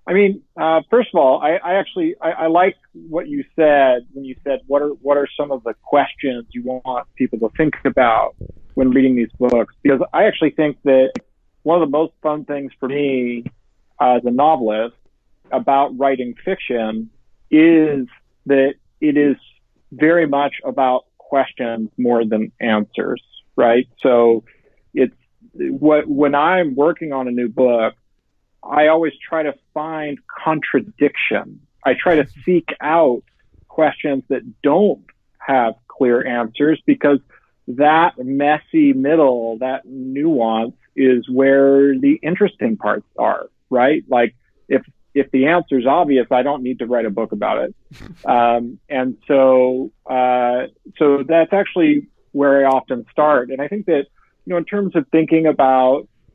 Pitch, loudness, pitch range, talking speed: 140 Hz, -17 LUFS, 125-160 Hz, 155 wpm